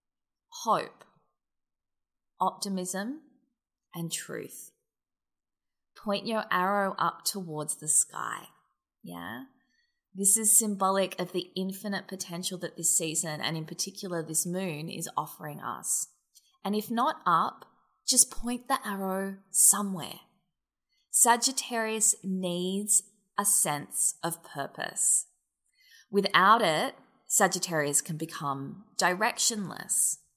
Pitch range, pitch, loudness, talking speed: 170-220 Hz, 195 Hz, -27 LUFS, 100 wpm